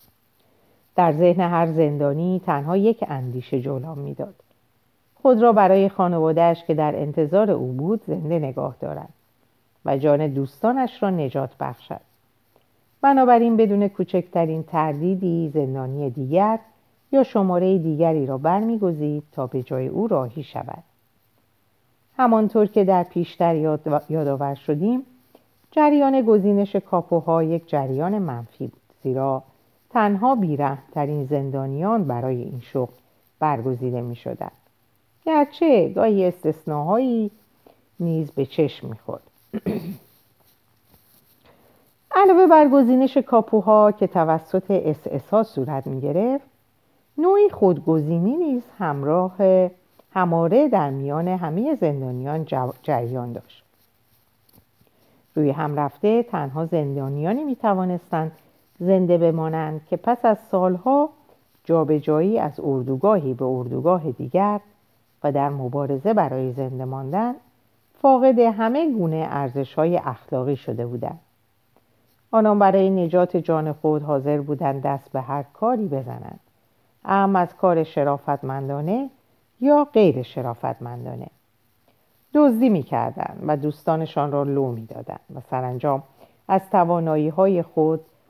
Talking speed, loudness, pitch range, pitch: 110 wpm, -21 LUFS, 135-195 Hz, 160 Hz